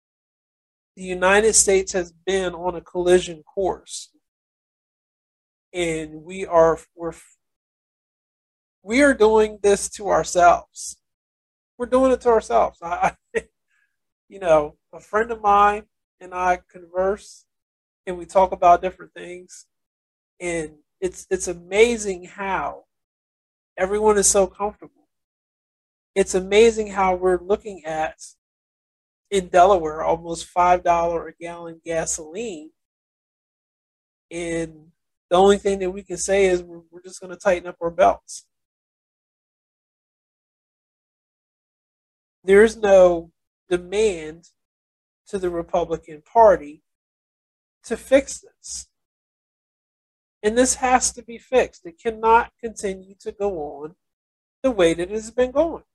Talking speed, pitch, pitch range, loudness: 120 wpm, 185 Hz, 170-210 Hz, -20 LUFS